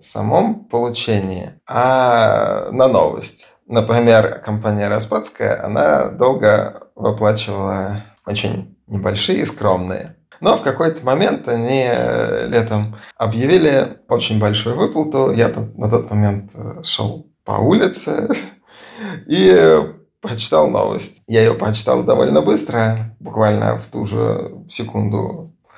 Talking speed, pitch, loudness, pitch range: 105 wpm, 110 Hz, -16 LUFS, 105-120 Hz